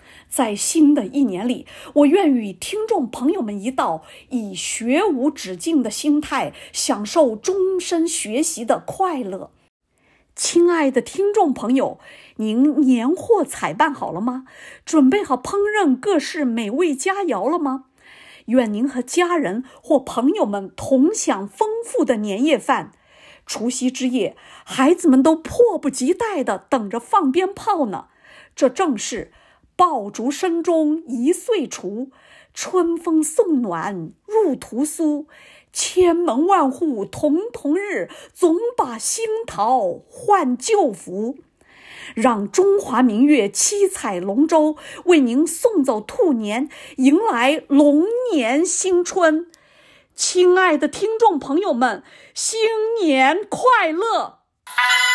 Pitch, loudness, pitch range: 300 Hz, -19 LUFS, 260-365 Hz